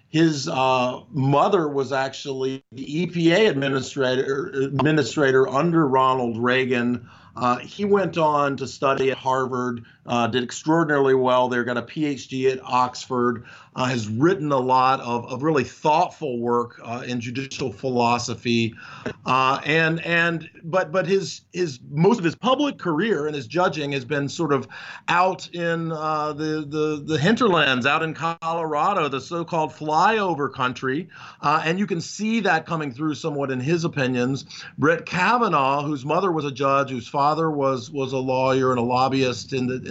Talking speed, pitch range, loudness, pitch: 160 wpm, 130-160 Hz, -22 LUFS, 140 Hz